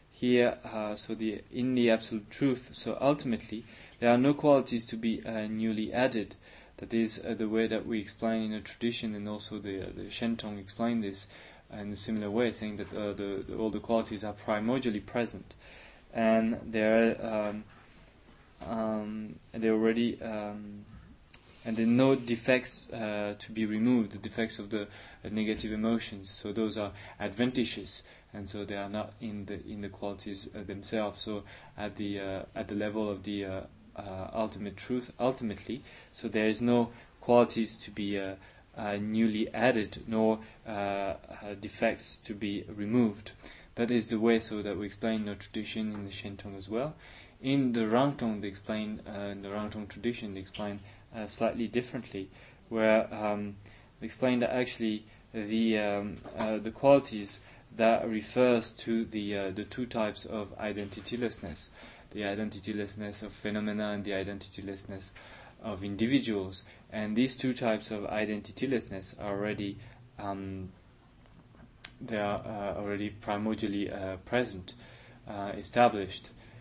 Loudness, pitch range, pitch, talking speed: -32 LUFS, 100-115 Hz, 110 Hz, 155 wpm